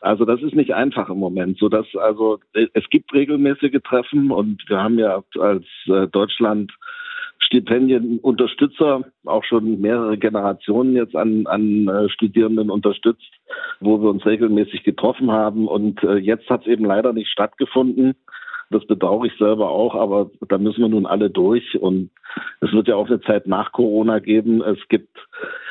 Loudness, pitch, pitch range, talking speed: -18 LUFS, 110 Hz, 105-130 Hz, 160 wpm